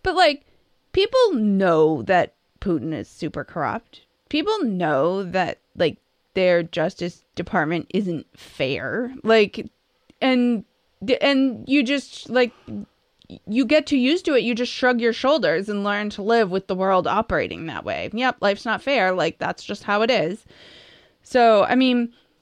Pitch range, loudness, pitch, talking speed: 190-260 Hz, -21 LUFS, 230 Hz, 155 wpm